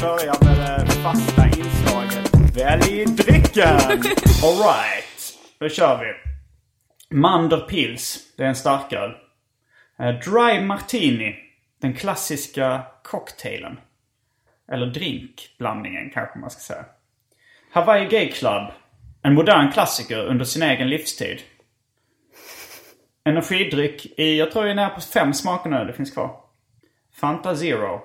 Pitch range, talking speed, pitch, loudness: 125-175 Hz, 115 wpm, 145 Hz, -19 LUFS